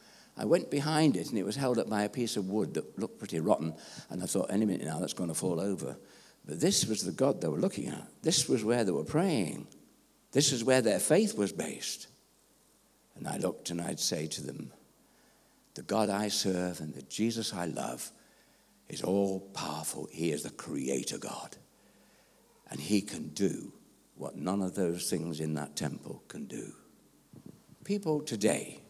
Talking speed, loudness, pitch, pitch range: 190 wpm, -32 LUFS, 100 Hz, 90-115 Hz